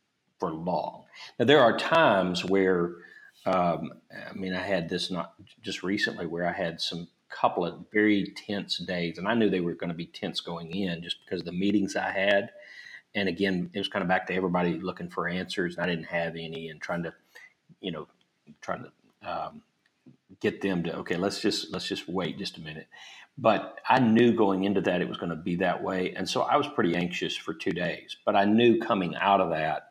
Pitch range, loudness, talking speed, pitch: 85-100 Hz, -28 LUFS, 220 wpm, 90 Hz